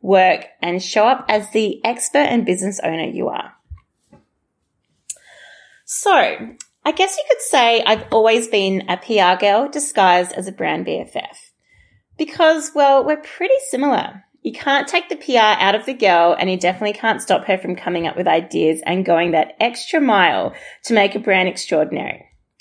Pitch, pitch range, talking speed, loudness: 215 Hz, 185-280 Hz, 170 wpm, -17 LUFS